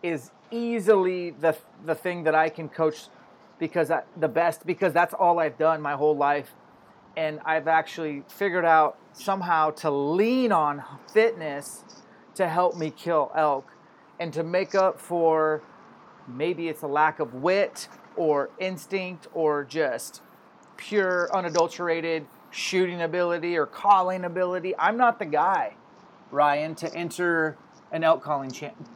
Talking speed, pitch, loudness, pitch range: 145 wpm, 165 Hz, -25 LUFS, 155-185 Hz